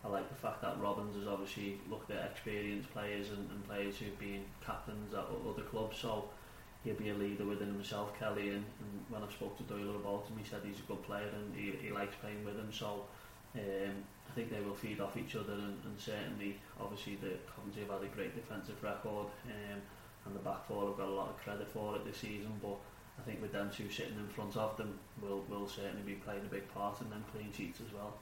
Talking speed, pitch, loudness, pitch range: 240 wpm, 105 Hz, -44 LUFS, 100-105 Hz